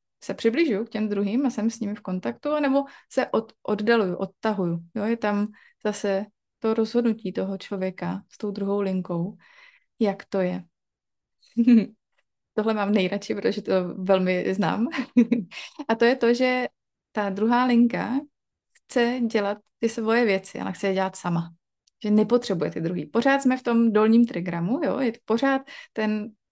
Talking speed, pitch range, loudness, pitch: 160 wpm, 195-240 Hz, -25 LUFS, 215 Hz